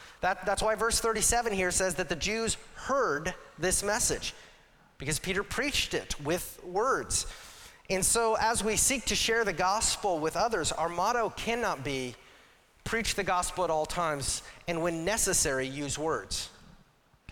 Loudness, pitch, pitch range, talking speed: -29 LUFS, 190 Hz, 170-225 Hz, 155 wpm